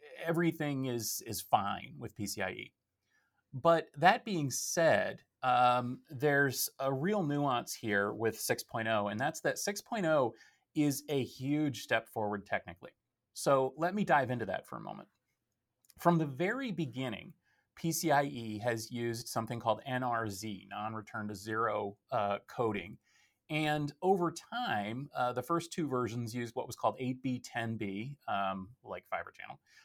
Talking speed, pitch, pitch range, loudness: 140 wpm, 125 Hz, 115-150 Hz, -34 LUFS